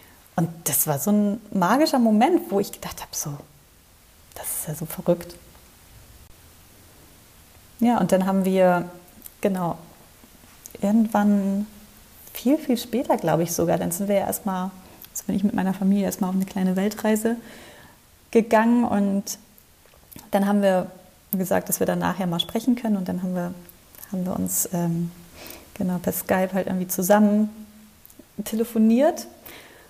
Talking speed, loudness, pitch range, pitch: 150 wpm, -23 LUFS, 170-215 Hz, 190 Hz